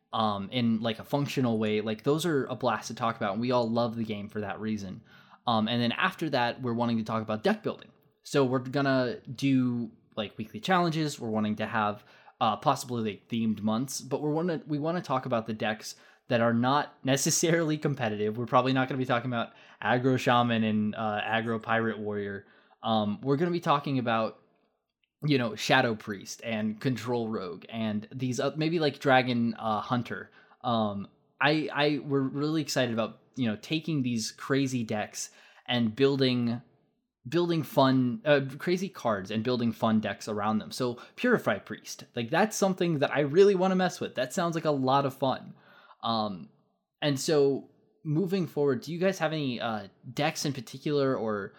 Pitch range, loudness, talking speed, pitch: 115-145 Hz, -29 LUFS, 195 wpm, 125 Hz